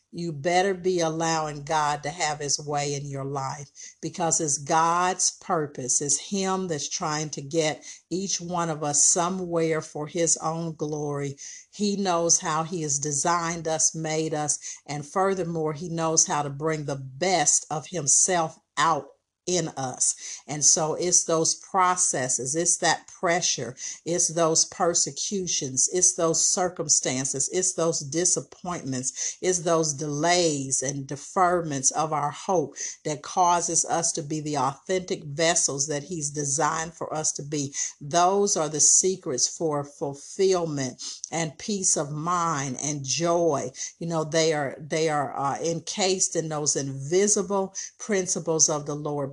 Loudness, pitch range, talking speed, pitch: -24 LUFS, 145-175 Hz, 145 wpm, 160 Hz